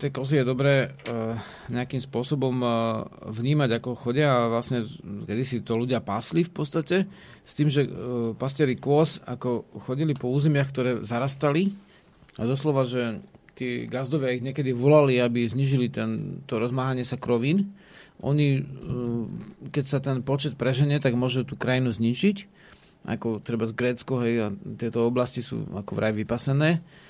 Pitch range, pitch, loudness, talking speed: 120-145 Hz, 130 Hz, -26 LUFS, 150 wpm